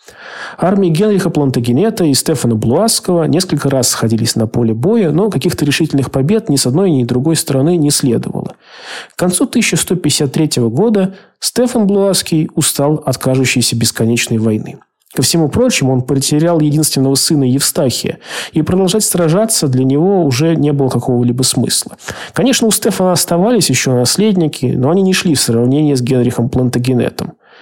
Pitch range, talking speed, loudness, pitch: 130-180 Hz, 150 wpm, -12 LUFS, 150 Hz